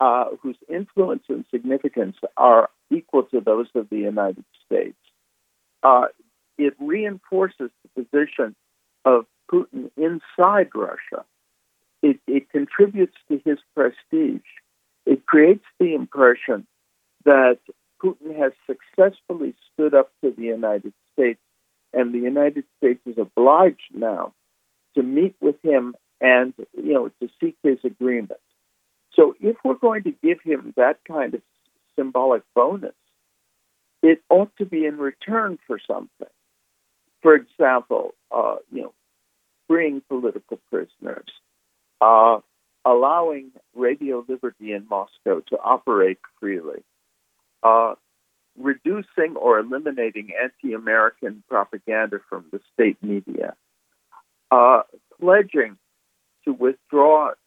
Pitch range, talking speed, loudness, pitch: 125-200 Hz, 115 wpm, -20 LUFS, 145 Hz